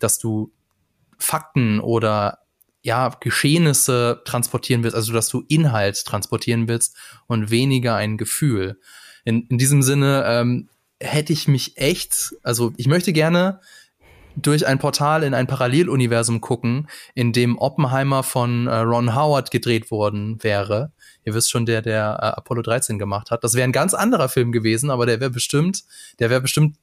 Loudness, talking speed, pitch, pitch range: -19 LUFS, 160 wpm, 125 Hz, 115-140 Hz